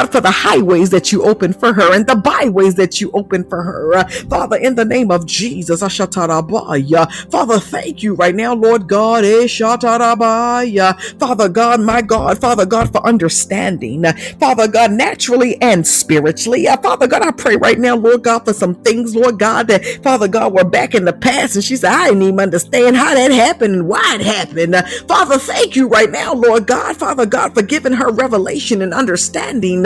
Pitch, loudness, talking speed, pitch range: 220 Hz, -12 LUFS, 195 wpm, 185-240 Hz